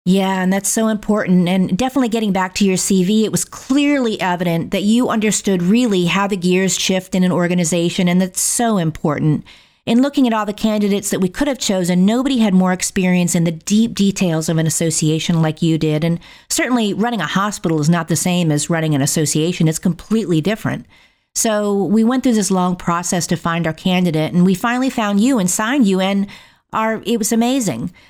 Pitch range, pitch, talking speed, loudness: 175-220 Hz, 190 Hz, 205 wpm, -16 LUFS